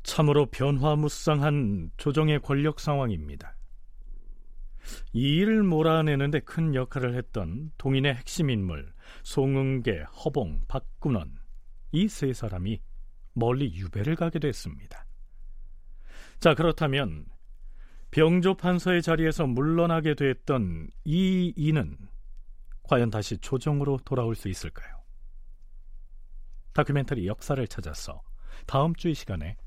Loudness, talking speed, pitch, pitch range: -27 LUFS, 245 characters per minute, 130 Hz, 95-150 Hz